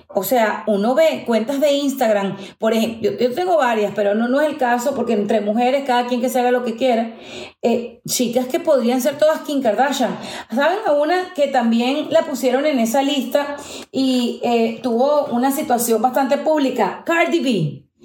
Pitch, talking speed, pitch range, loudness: 255 Hz, 190 wpm, 230-285 Hz, -18 LUFS